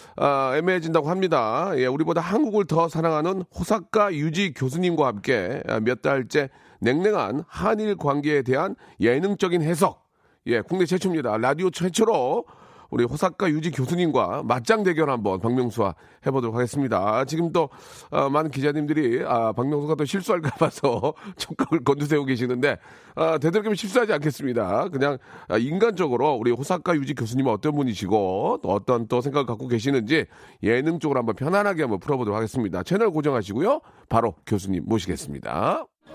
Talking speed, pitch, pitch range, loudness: 370 characters per minute, 150 Hz, 130-180 Hz, -24 LUFS